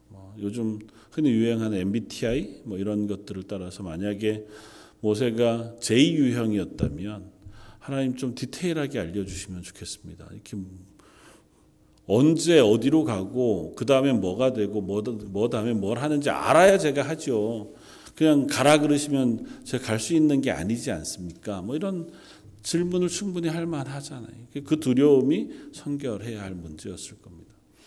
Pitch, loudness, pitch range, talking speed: 115 Hz, -25 LUFS, 105-140 Hz, 305 characters per minute